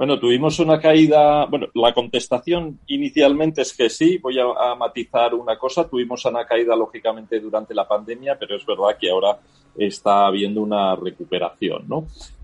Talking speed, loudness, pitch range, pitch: 165 wpm, -19 LUFS, 110-150 Hz, 120 Hz